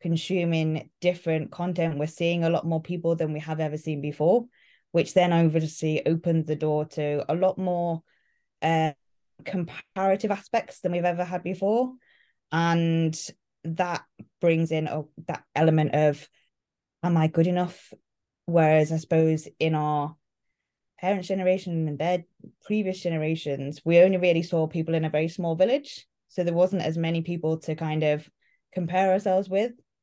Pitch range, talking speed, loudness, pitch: 155-180 Hz, 155 wpm, -26 LUFS, 165 Hz